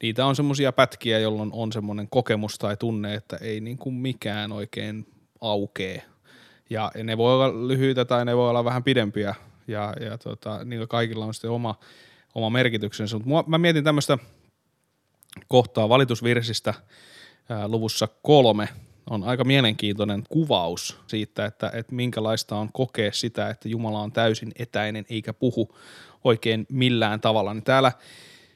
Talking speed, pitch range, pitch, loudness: 145 wpm, 105-125 Hz, 115 Hz, -24 LUFS